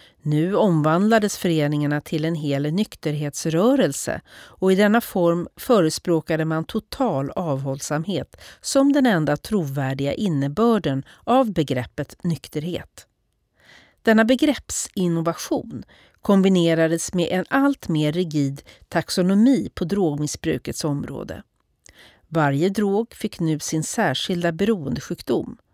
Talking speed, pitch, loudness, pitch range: 100 wpm, 170 Hz, -22 LUFS, 150-205 Hz